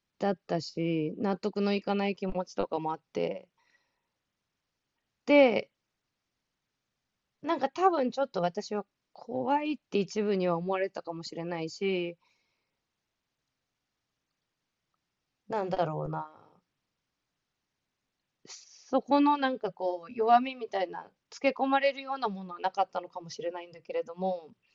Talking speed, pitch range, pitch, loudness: 240 characters per minute, 175-260 Hz, 200 Hz, -30 LUFS